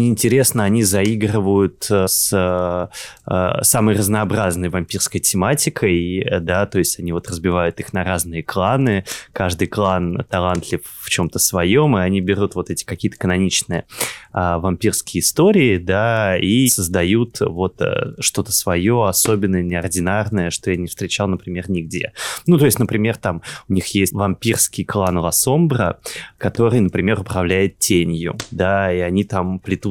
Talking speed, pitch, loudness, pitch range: 135 wpm, 95 Hz, -18 LUFS, 90-110 Hz